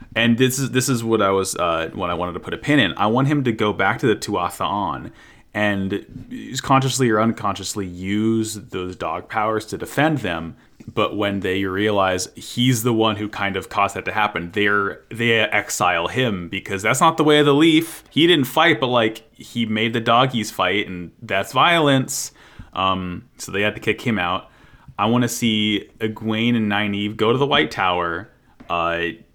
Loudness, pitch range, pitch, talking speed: -20 LUFS, 95-120 Hz, 110 Hz, 200 wpm